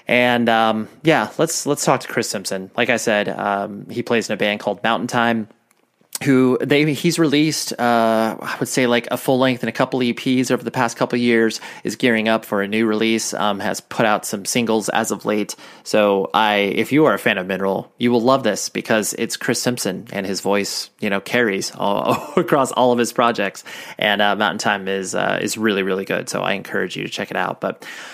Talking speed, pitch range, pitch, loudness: 230 wpm, 105-125 Hz, 115 Hz, -19 LUFS